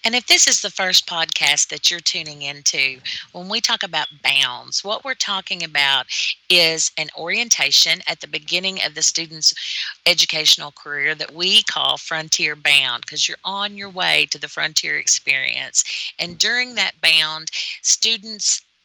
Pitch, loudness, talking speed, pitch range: 165 Hz, -17 LUFS, 160 wpm, 150-195 Hz